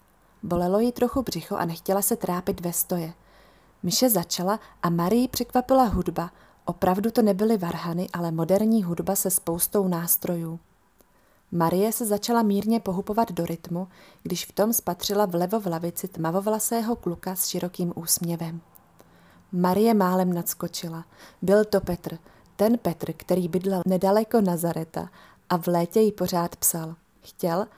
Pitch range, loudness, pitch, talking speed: 170-205 Hz, -25 LUFS, 180 Hz, 140 wpm